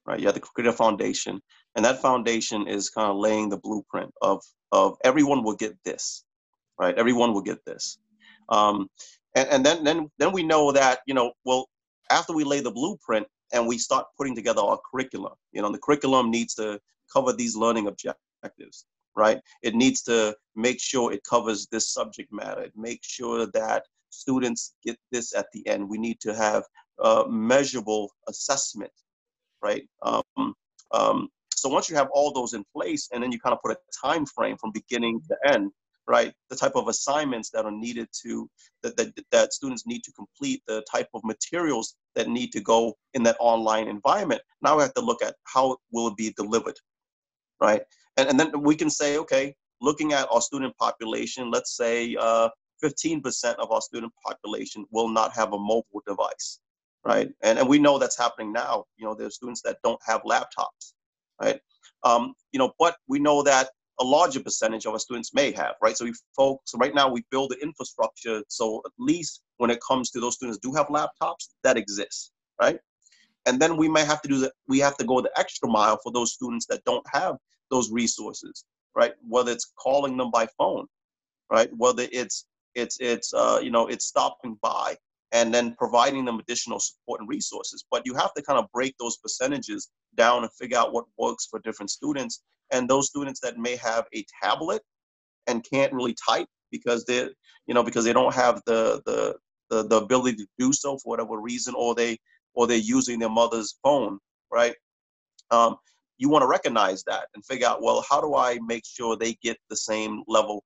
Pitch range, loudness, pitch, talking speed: 115-145 Hz, -25 LUFS, 120 Hz, 200 wpm